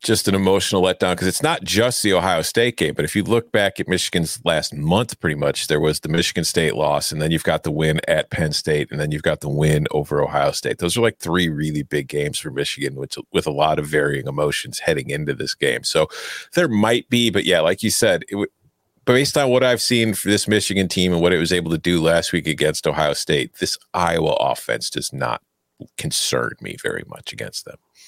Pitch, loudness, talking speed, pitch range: 90 Hz, -19 LUFS, 235 wpm, 75-105 Hz